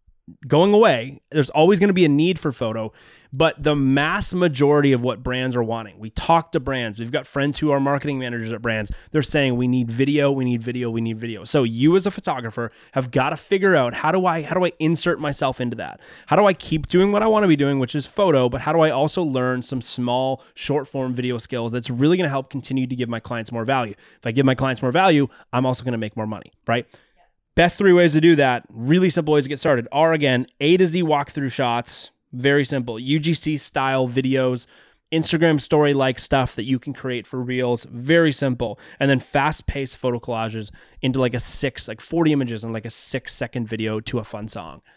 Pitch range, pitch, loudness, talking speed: 125-155 Hz, 135 Hz, -20 LUFS, 235 wpm